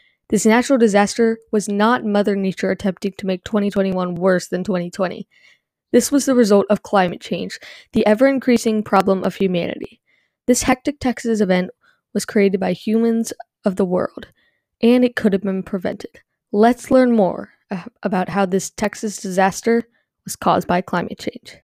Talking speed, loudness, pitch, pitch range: 160 wpm, -18 LUFS, 210 Hz, 195-230 Hz